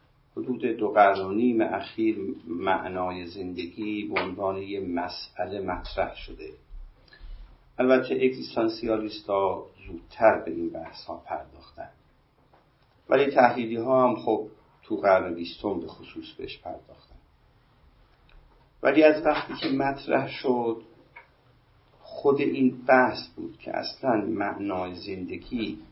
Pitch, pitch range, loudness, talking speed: 115 Hz, 95-130 Hz, -26 LUFS, 110 wpm